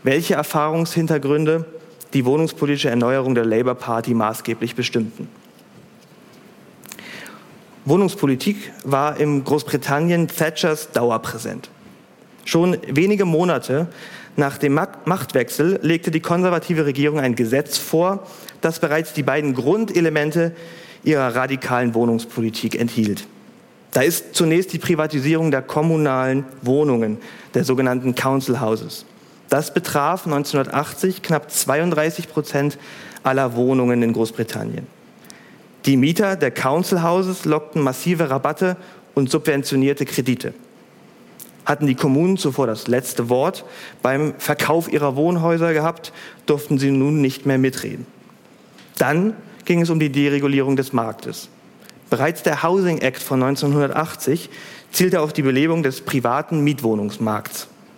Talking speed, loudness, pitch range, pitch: 115 wpm, -20 LUFS, 130-165 Hz, 145 Hz